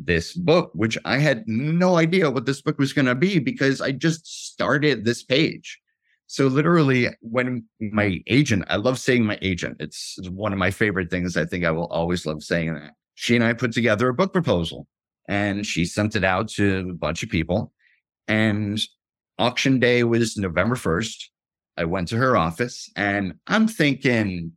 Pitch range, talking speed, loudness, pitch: 90-135 Hz, 190 wpm, -22 LUFS, 110 Hz